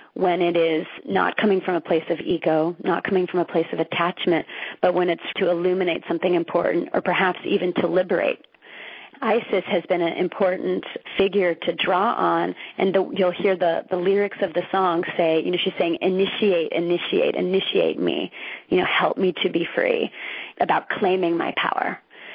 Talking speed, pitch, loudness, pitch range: 180 wpm, 180 Hz, -22 LUFS, 170-190 Hz